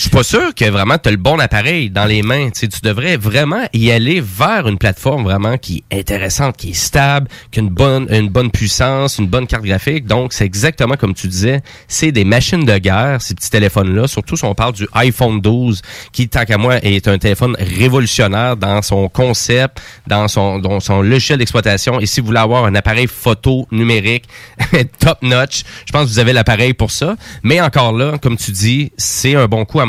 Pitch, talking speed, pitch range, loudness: 115 Hz, 220 wpm, 105-130 Hz, -13 LUFS